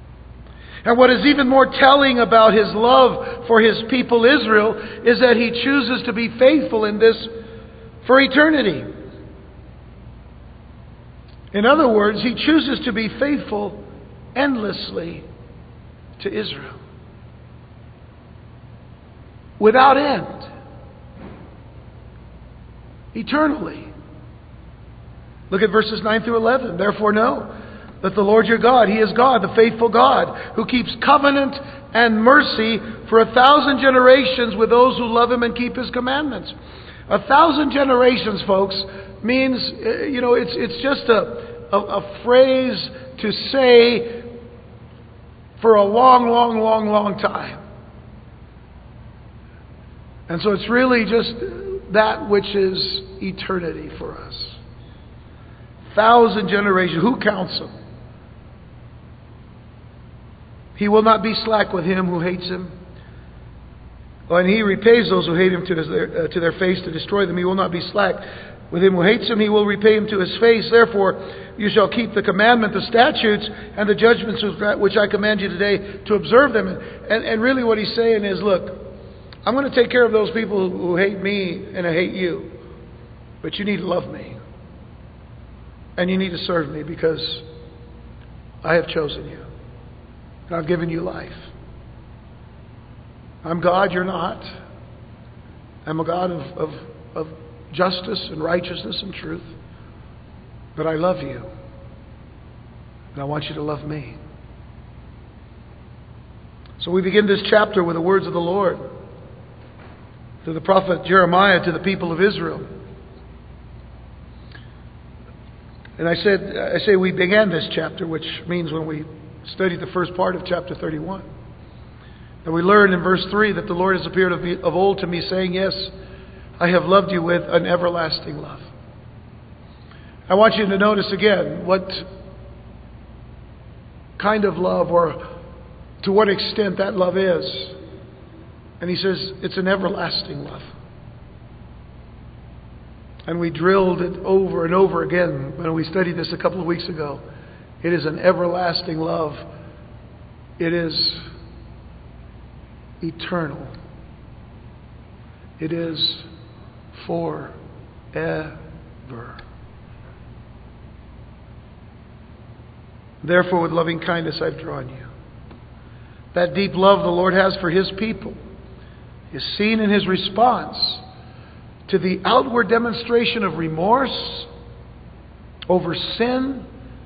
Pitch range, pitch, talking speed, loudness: 165-225 Hz, 190 Hz, 135 wpm, -18 LUFS